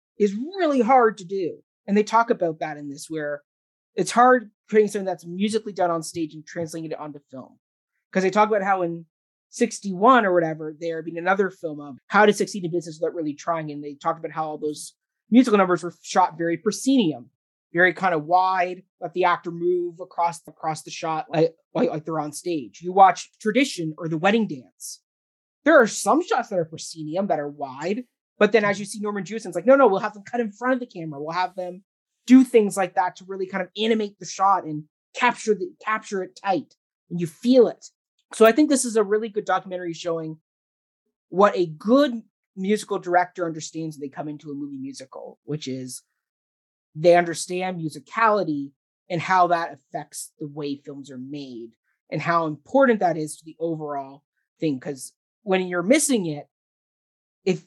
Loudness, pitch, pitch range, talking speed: -22 LUFS, 175 Hz, 155-210 Hz, 205 wpm